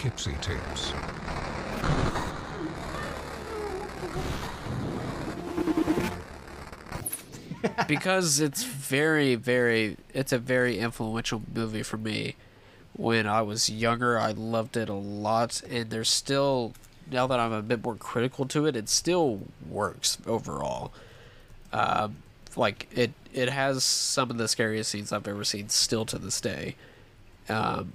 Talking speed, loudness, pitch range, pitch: 115 wpm, -28 LUFS, 110-130 Hz, 115 Hz